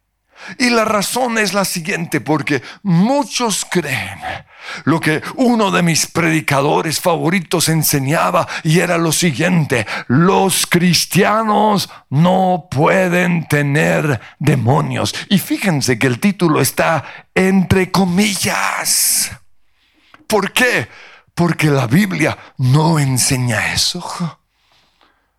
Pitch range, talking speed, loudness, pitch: 150-190 Hz, 100 wpm, -15 LUFS, 170 Hz